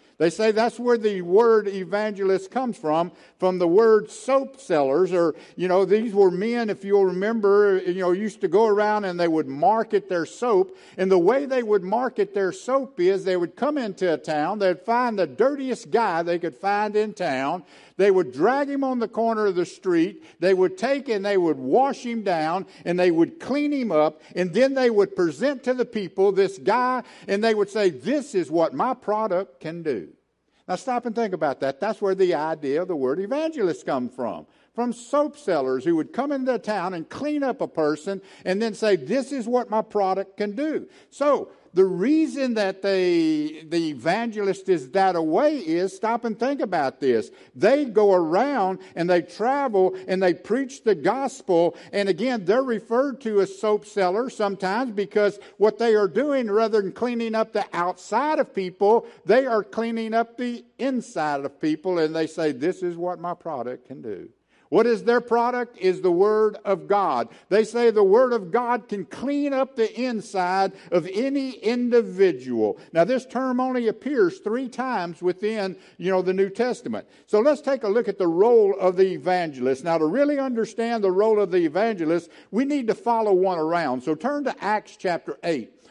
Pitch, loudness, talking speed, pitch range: 210 Hz, -23 LUFS, 195 wpm, 185-245 Hz